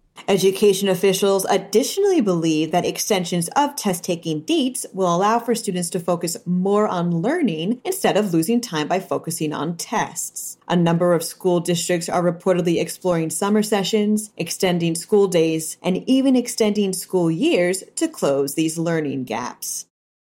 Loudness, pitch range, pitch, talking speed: -20 LUFS, 165-210 Hz, 180 Hz, 145 wpm